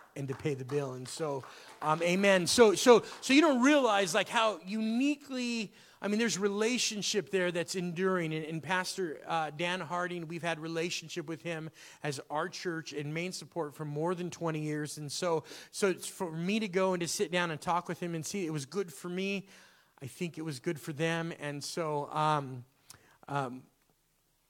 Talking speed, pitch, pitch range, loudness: 200 wpm, 170 Hz, 155-195 Hz, -32 LUFS